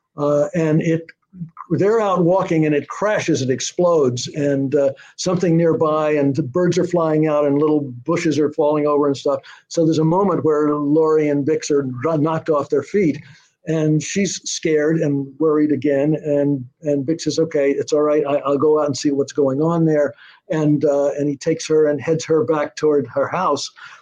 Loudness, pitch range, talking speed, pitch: -18 LUFS, 145-160 Hz, 195 wpm, 155 Hz